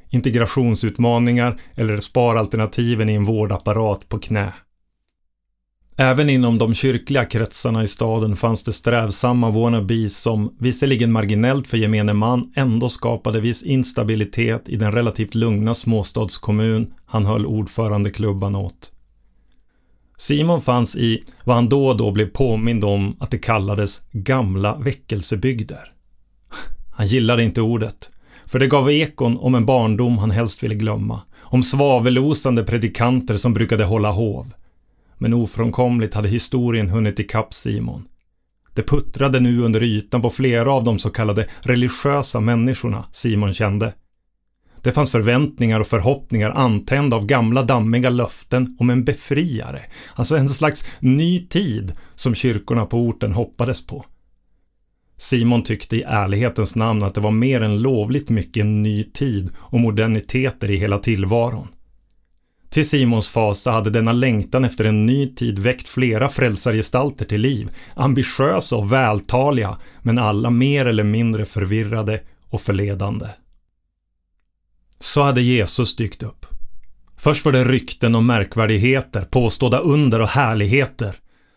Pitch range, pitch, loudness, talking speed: 105-125 Hz, 115 Hz, -18 LUFS, 135 wpm